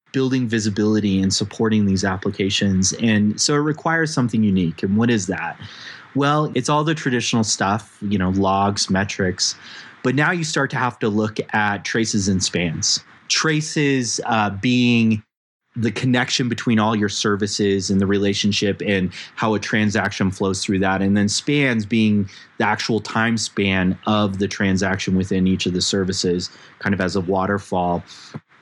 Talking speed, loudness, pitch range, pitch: 165 wpm, -20 LUFS, 95-115 Hz, 105 Hz